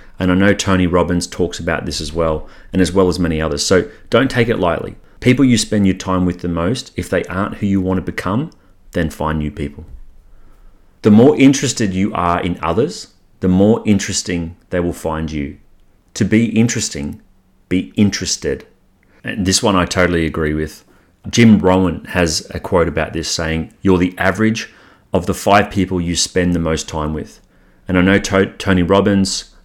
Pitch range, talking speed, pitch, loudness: 85-100 Hz, 190 wpm, 90 Hz, -16 LUFS